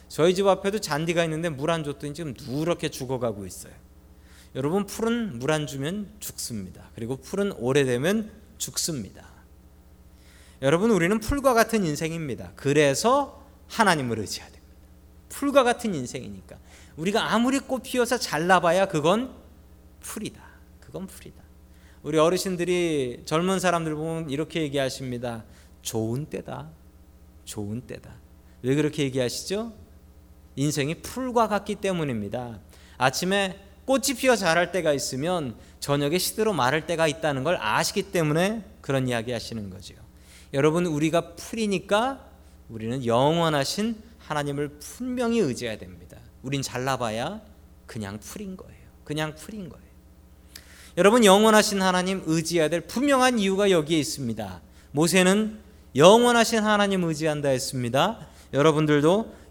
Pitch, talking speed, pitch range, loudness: 155 Hz, 320 characters per minute, 115-195 Hz, -24 LUFS